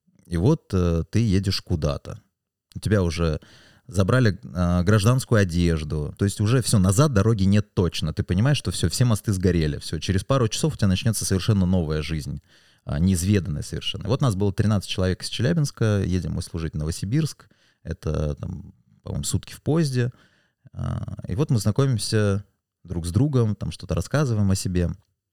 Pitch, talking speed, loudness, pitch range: 100 Hz, 175 wpm, -23 LUFS, 90-115 Hz